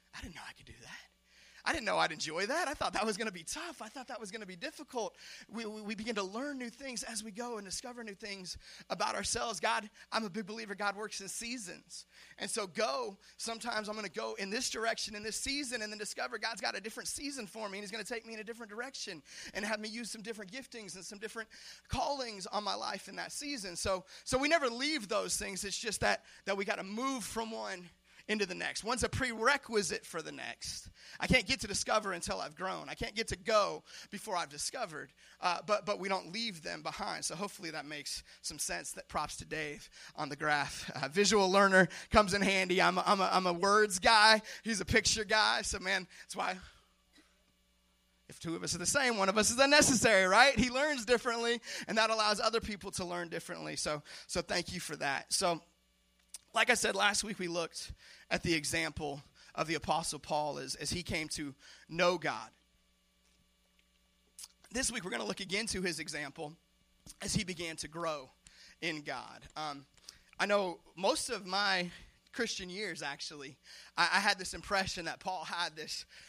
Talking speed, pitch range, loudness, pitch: 220 wpm, 180-230 Hz, -34 LUFS, 205 Hz